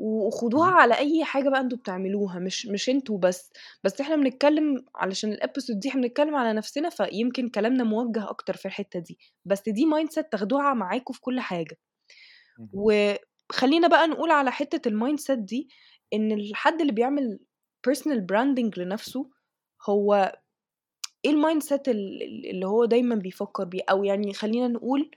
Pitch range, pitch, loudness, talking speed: 205-280 Hz, 235 Hz, -25 LUFS, 155 wpm